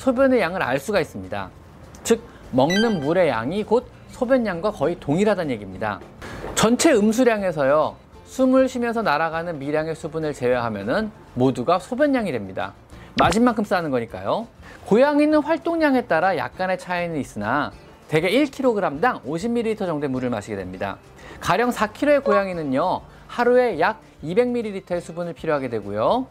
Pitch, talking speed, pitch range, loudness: 205 Hz, 335 characters per minute, 150-245 Hz, -22 LUFS